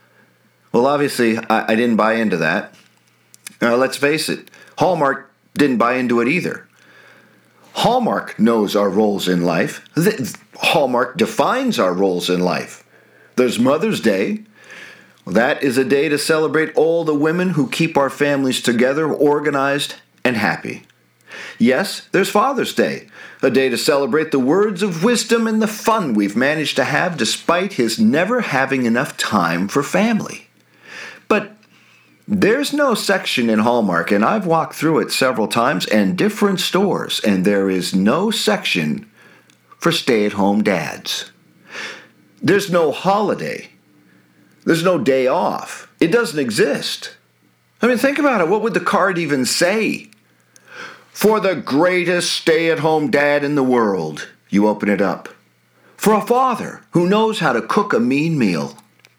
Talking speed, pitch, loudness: 150 wpm, 145 Hz, -17 LUFS